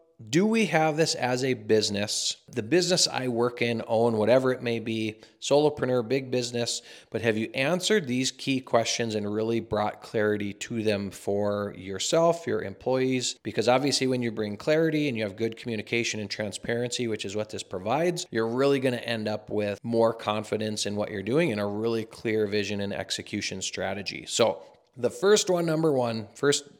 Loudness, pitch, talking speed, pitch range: -27 LUFS, 115 Hz, 185 wpm, 105-135 Hz